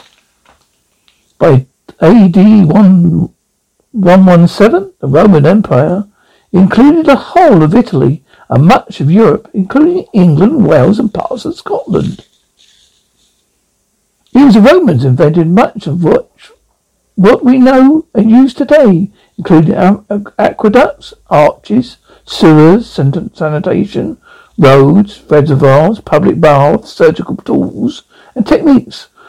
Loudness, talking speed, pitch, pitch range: -8 LUFS, 100 wpm, 205 Hz, 170-260 Hz